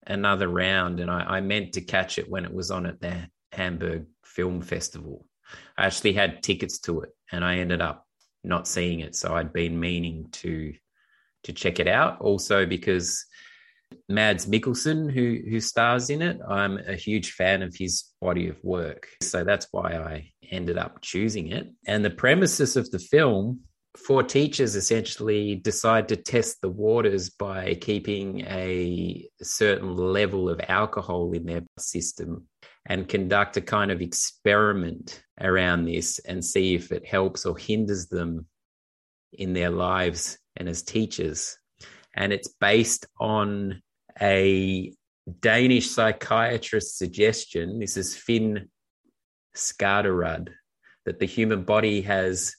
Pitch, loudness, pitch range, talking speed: 95 Hz, -25 LUFS, 85-105 Hz, 145 wpm